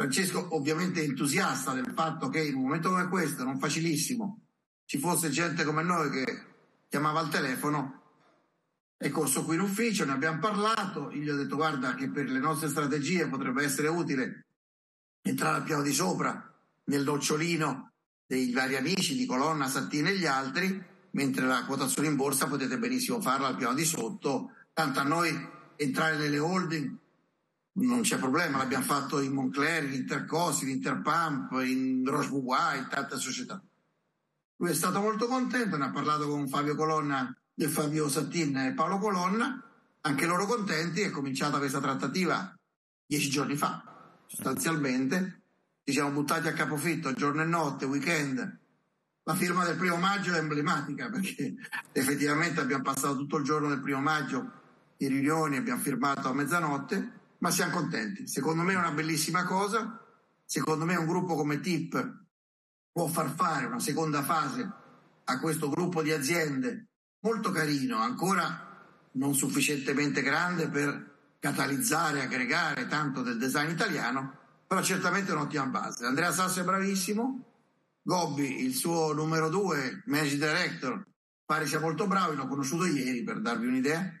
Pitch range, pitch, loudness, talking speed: 140-180 Hz, 155 Hz, -30 LUFS, 155 wpm